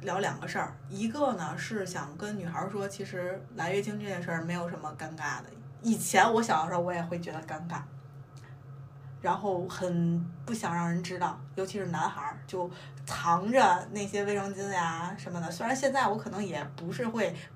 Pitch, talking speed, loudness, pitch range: 175 Hz, 275 characters per minute, -32 LUFS, 150-195 Hz